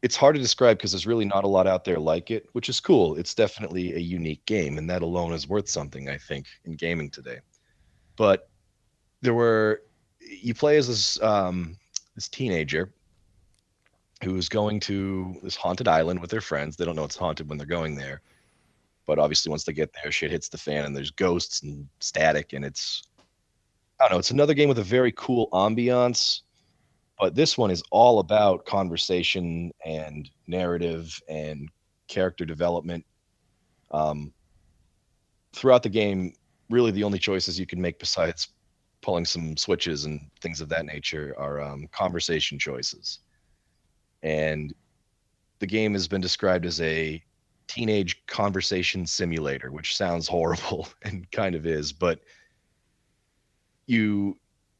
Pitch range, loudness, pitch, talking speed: 80-105 Hz, -25 LUFS, 90 Hz, 160 wpm